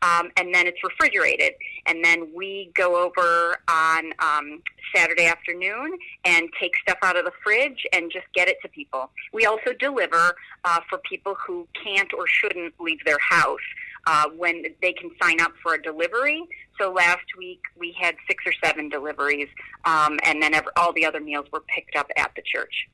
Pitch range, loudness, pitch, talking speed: 165-200 Hz, -21 LUFS, 175 Hz, 185 wpm